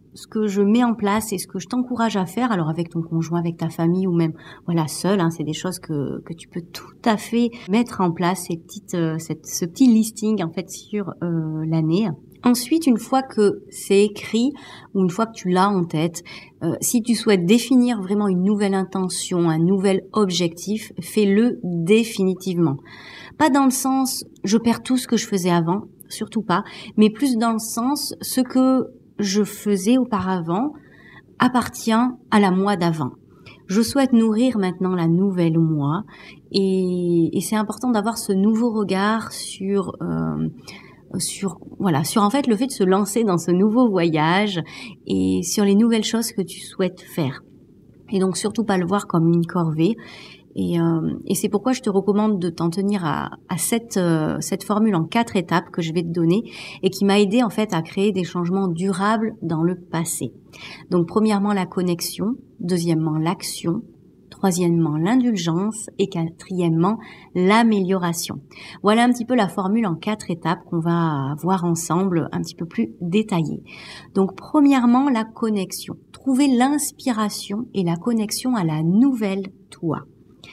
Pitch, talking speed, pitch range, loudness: 195 Hz, 175 wpm, 175-220 Hz, -21 LUFS